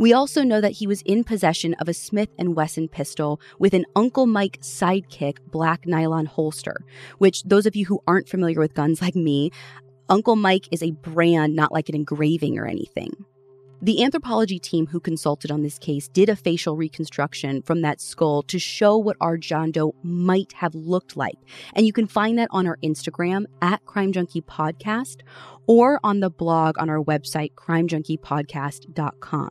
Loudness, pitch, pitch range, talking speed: -22 LUFS, 165 Hz, 155-195 Hz, 180 wpm